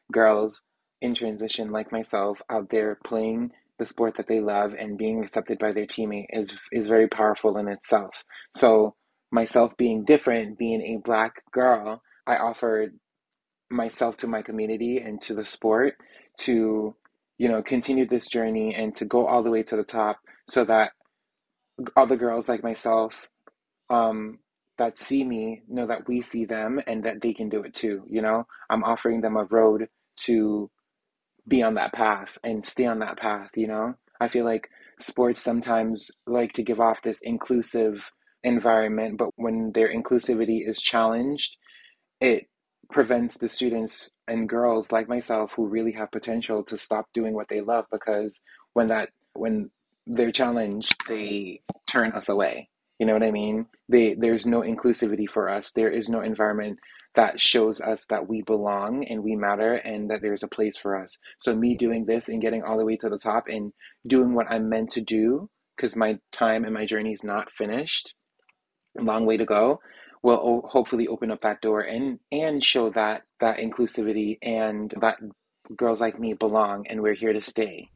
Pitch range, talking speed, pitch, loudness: 110-120 Hz, 180 wpm, 110 Hz, -25 LUFS